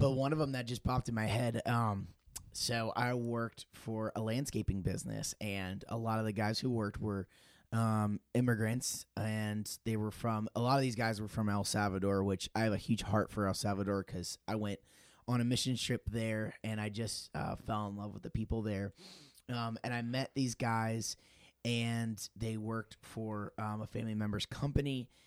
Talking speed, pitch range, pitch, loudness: 200 wpm, 105-120 Hz, 110 Hz, -37 LUFS